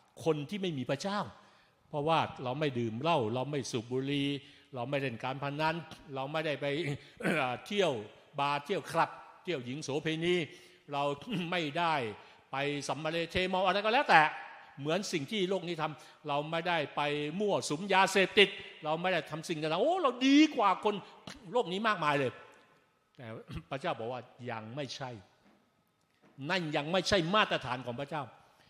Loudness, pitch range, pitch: -32 LUFS, 140-185 Hz, 155 Hz